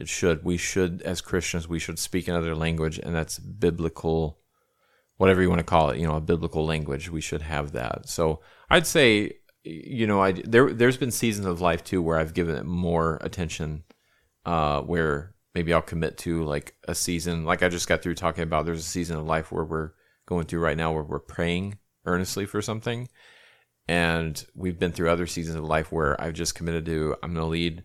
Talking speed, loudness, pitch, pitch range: 210 wpm, -26 LUFS, 85 Hz, 80-90 Hz